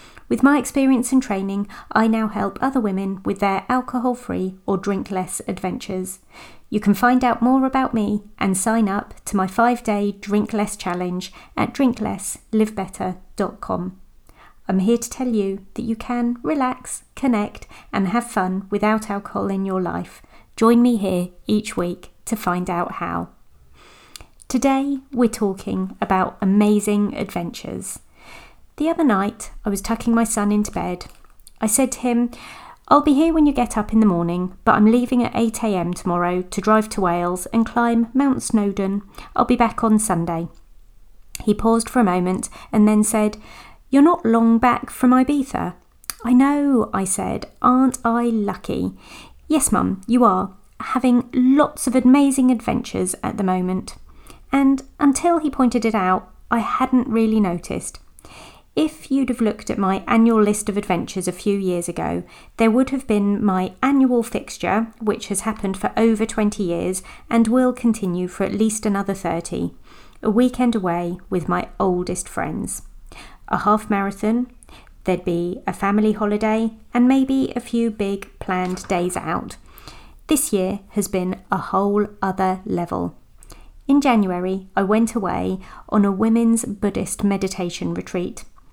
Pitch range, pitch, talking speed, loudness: 190-245 Hz, 215 Hz, 160 wpm, -20 LUFS